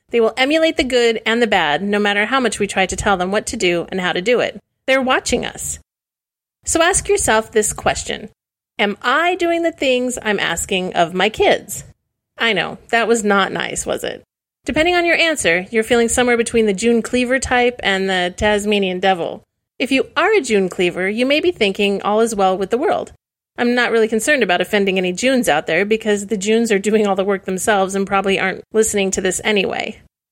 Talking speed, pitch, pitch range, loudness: 215 wpm, 220 Hz, 195-250 Hz, -16 LUFS